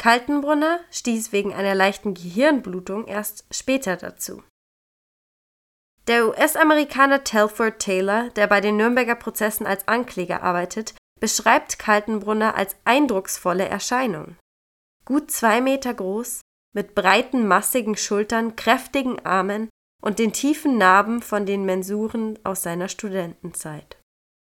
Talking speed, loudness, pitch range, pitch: 115 wpm, -21 LUFS, 195-240 Hz, 215 Hz